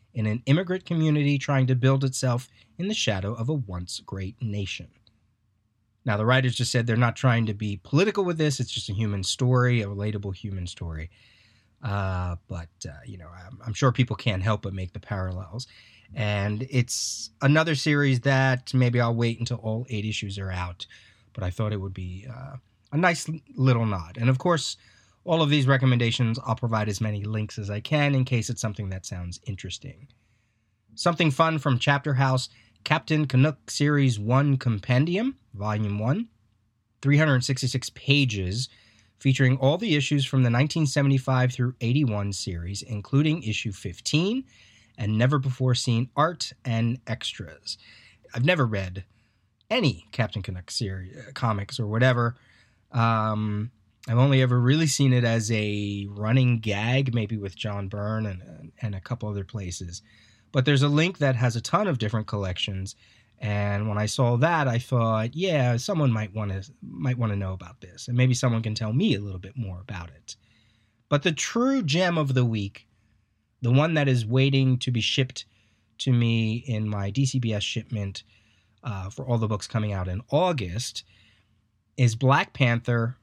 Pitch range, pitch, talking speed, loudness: 105-130 Hz, 115 Hz, 175 wpm, -25 LUFS